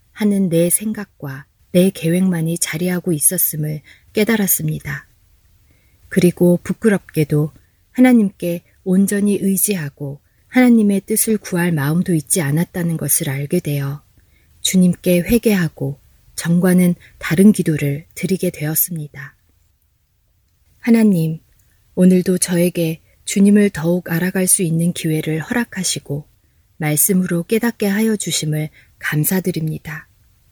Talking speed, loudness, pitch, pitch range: 265 characters per minute, -17 LUFS, 170 Hz, 145-185 Hz